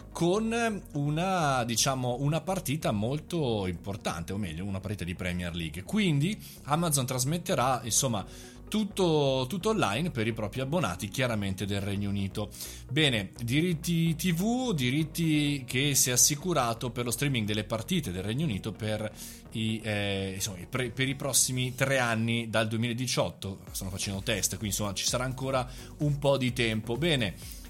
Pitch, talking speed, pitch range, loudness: 125 Hz, 155 wpm, 105-150 Hz, -29 LUFS